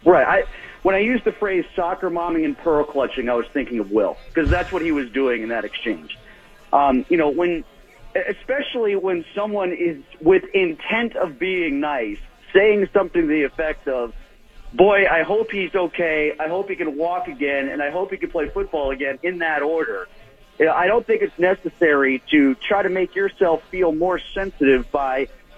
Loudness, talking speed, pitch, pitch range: -20 LUFS, 195 wpm, 180 Hz, 145-200 Hz